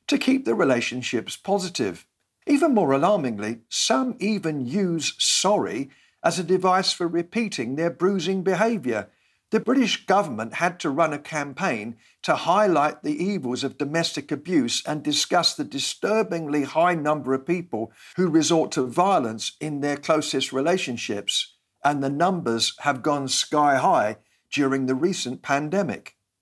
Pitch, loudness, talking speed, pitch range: 160 Hz, -23 LUFS, 140 wpm, 140-190 Hz